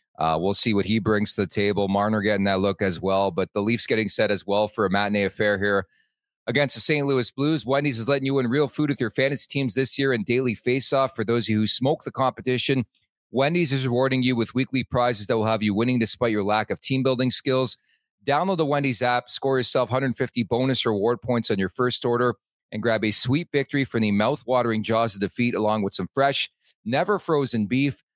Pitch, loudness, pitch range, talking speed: 120 Hz, -22 LUFS, 105-135 Hz, 230 wpm